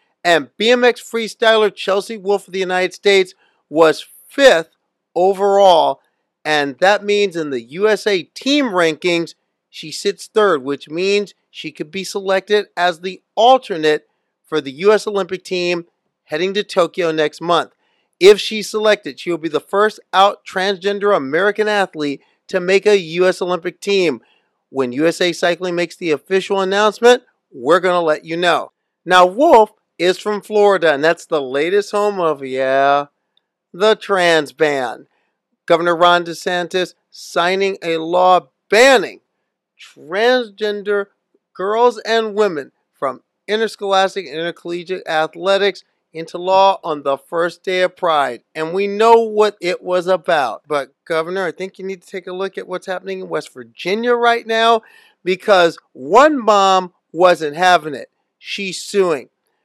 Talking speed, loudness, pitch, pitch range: 145 wpm, -16 LUFS, 185 Hz, 170-205 Hz